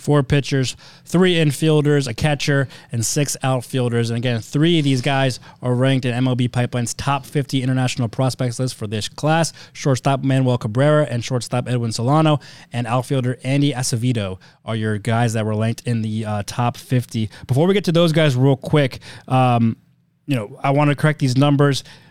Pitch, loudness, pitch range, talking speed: 130 Hz, -19 LUFS, 120-145 Hz, 180 wpm